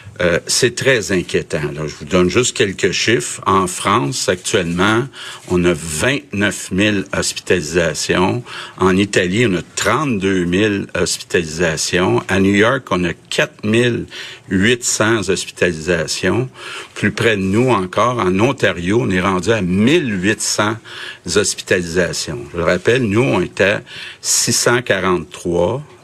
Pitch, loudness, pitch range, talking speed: 95 Hz, -16 LUFS, 90-115 Hz, 125 wpm